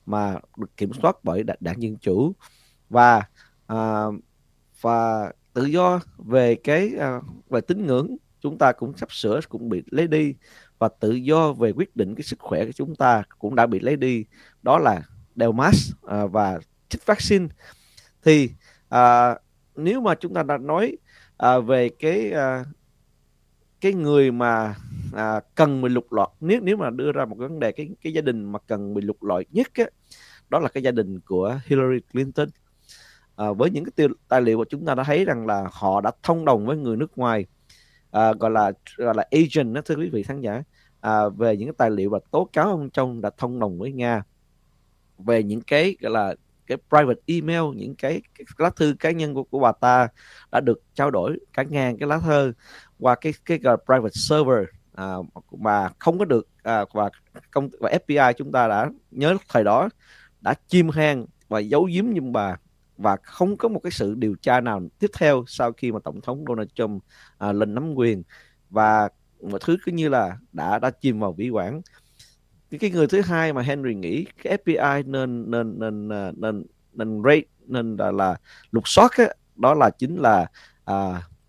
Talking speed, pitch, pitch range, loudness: 195 wpm, 125 Hz, 110-155 Hz, -22 LUFS